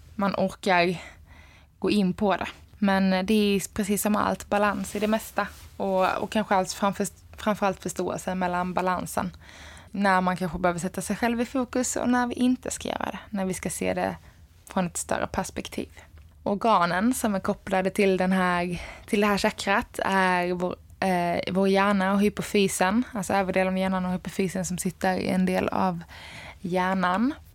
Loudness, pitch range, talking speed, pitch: -26 LUFS, 180-205 Hz, 180 wpm, 190 Hz